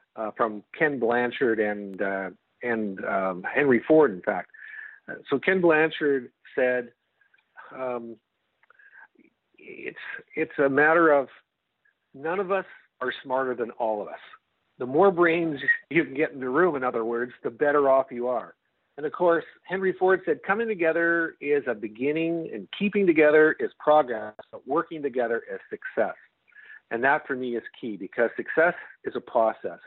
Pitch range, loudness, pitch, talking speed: 125-175 Hz, -25 LUFS, 150 Hz, 165 wpm